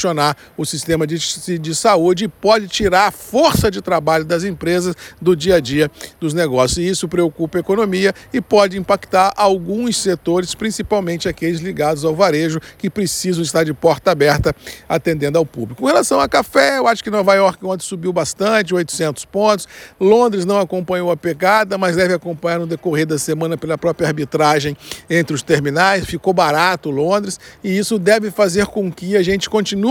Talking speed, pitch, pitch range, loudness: 175 wpm, 180 Hz, 160-195 Hz, -16 LUFS